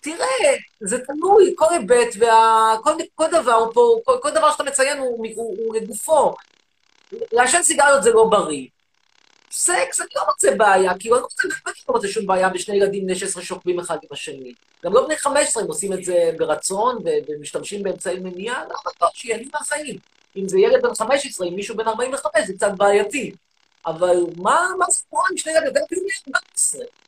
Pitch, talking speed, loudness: 265 Hz, 180 wpm, -19 LUFS